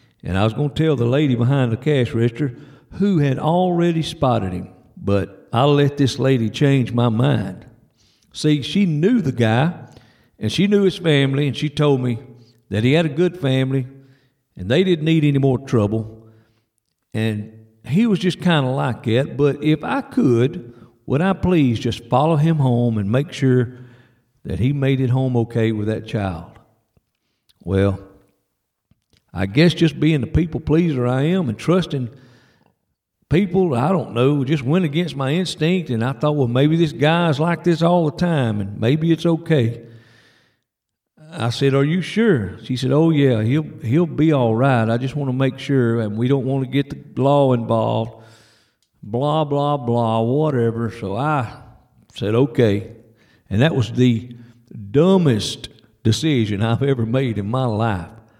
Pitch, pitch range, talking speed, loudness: 130 Hz, 115-150 Hz, 175 wpm, -19 LUFS